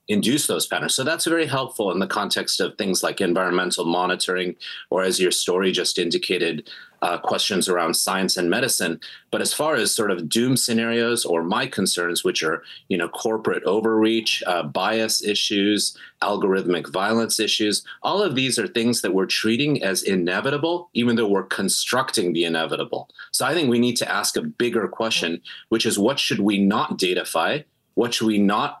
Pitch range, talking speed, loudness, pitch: 95-120 Hz, 180 wpm, -21 LUFS, 110 Hz